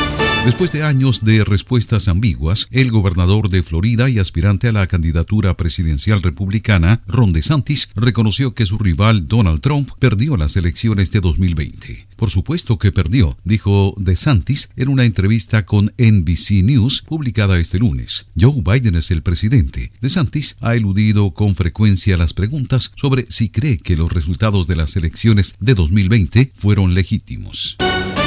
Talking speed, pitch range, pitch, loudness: 150 wpm, 95-120 Hz, 105 Hz, -15 LUFS